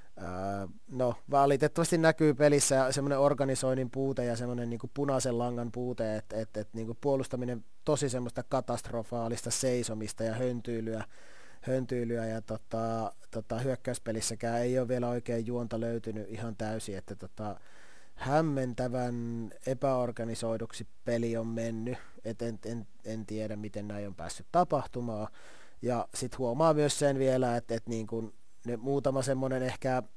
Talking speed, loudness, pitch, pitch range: 130 wpm, -32 LUFS, 120 Hz, 110-130 Hz